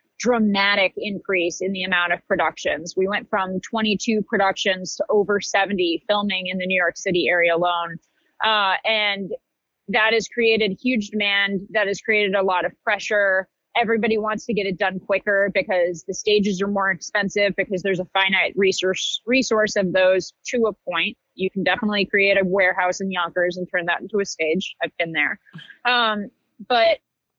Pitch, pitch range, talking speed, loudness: 195 Hz, 185-210 Hz, 175 wpm, -21 LUFS